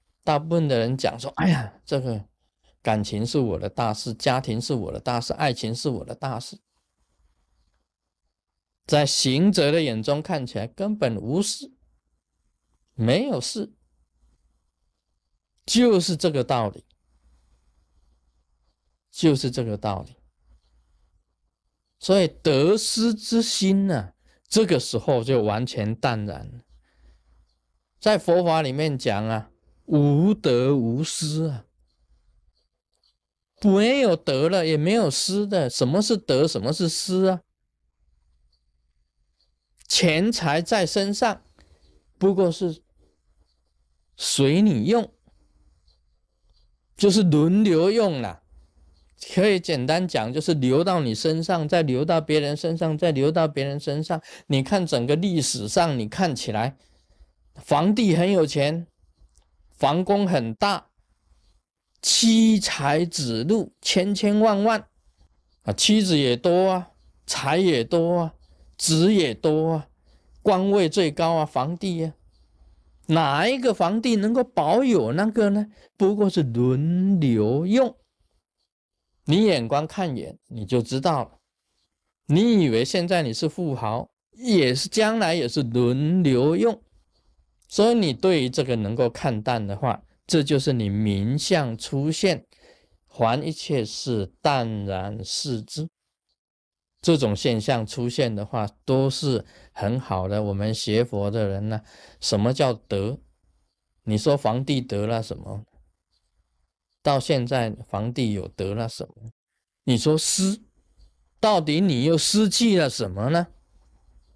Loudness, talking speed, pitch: -22 LUFS, 175 characters per minute, 130 Hz